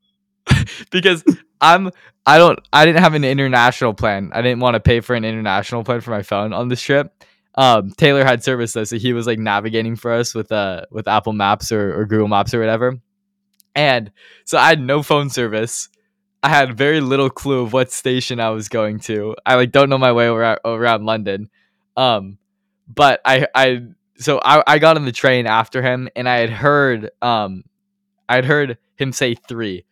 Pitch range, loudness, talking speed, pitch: 110-145 Hz, -16 LUFS, 200 wpm, 125 Hz